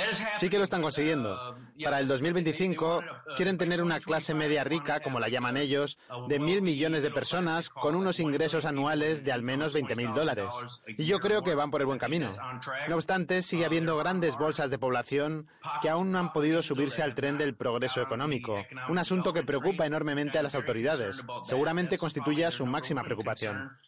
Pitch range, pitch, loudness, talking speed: 135-165 Hz, 150 Hz, -30 LUFS, 185 wpm